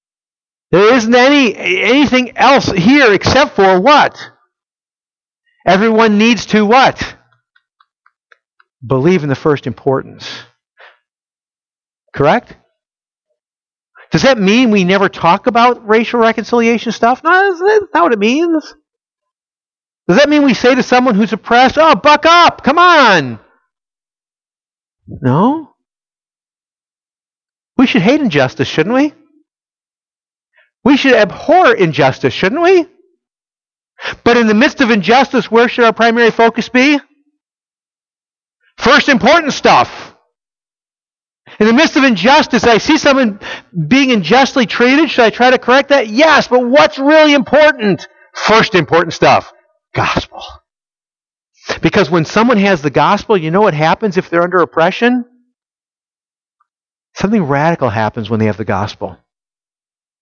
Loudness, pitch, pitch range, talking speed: -10 LUFS, 240 Hz, 195-285 Hz, 125 wpm